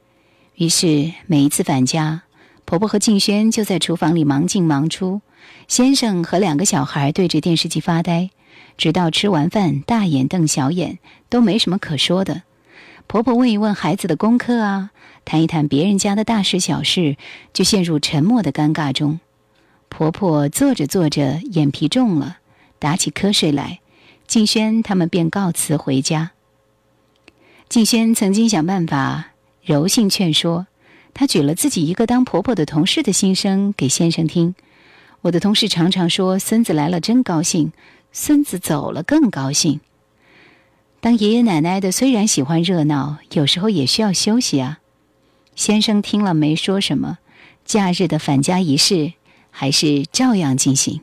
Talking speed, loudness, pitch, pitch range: 235 characters per minute, -17 LUFS, 170 Hz, 150-205 Hz